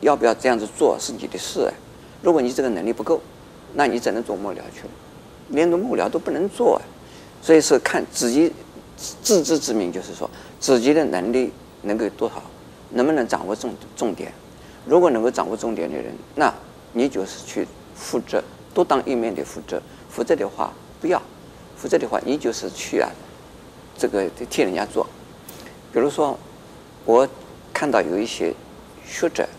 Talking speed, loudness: 255 characters per minute, -22 LUFS